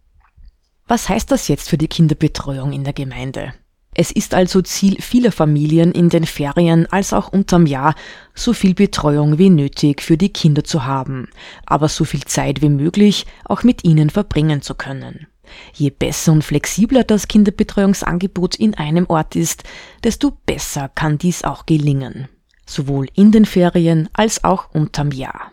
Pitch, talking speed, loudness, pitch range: 160 Hz, 160 wpm, -16 LUFS, 145-195 Hz